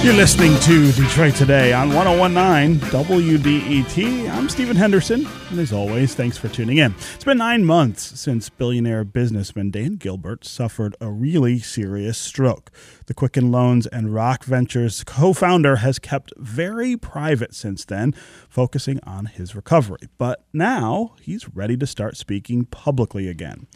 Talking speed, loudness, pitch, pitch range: 145 wpm, -18 LUFS, 130 Hz, 115-155 Hz